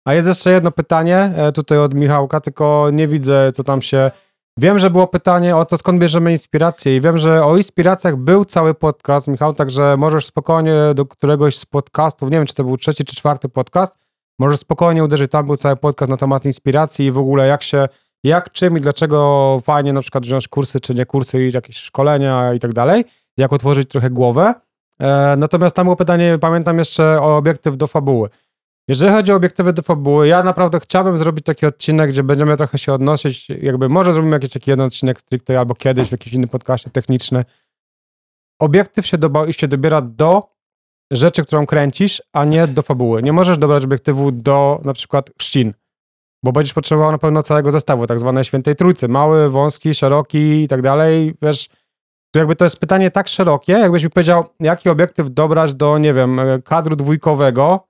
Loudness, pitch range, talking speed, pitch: -14 LUFS, 135-165 Hz, 190 wpm, 150 Hz